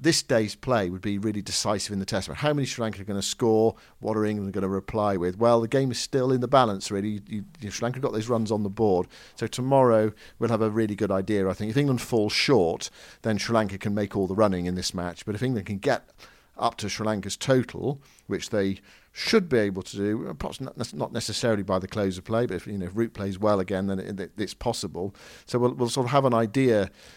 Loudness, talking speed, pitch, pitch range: -26 LUFS, 255 wpm, 110 Hz, 100-115 Hz